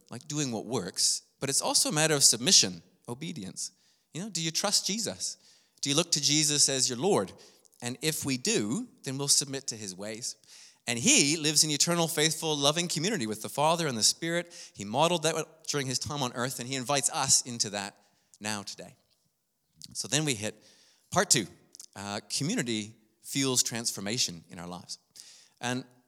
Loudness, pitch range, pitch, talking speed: -27 LUFS, 110-155 Hz, 135 Hz, 185 wpm